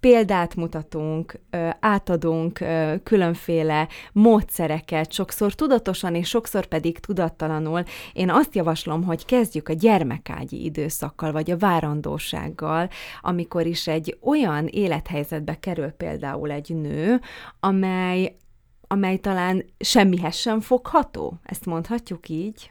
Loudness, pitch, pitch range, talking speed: -23 LUFS, 170 Hz, 160-200 Hz, 105 wpm